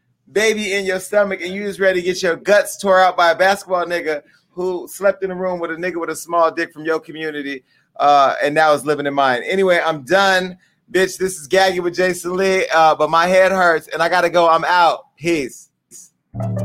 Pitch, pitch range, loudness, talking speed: 175 Hz, 160-185 Hz, -16 LUFS, 225 wpm